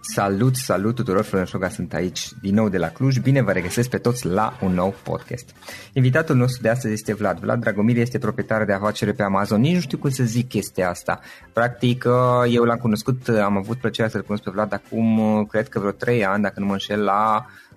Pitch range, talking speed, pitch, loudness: 100-120 Hz, 220 wpm, 110 Hz, -21 LUFS